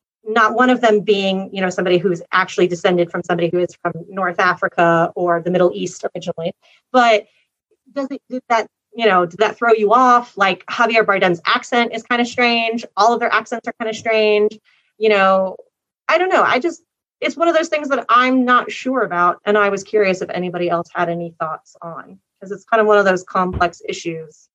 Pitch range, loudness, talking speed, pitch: 180-235 Hz, -17 LUFS, 215 wpm, 205 Hz